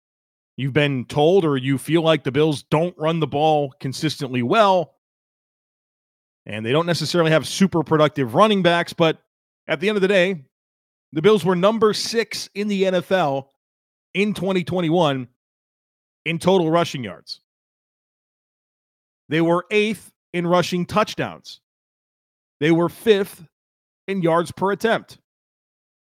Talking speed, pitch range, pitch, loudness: 135 wpm, 140-185 Hz, 165 Hz, -20 LUFS